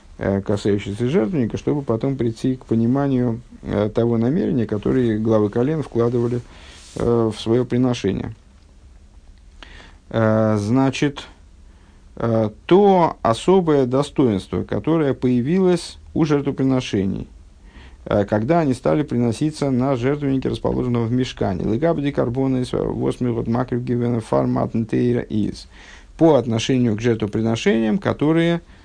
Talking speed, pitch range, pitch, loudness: 85 wpm, 105-135 Hz, 120 Hz, -20 LUFS